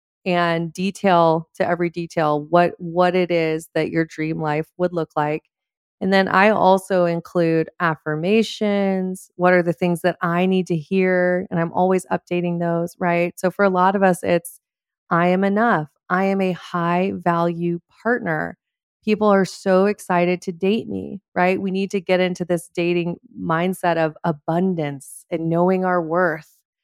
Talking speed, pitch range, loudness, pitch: 170 wpm, 170-190 Hz, -20 LUFS, 180 Hz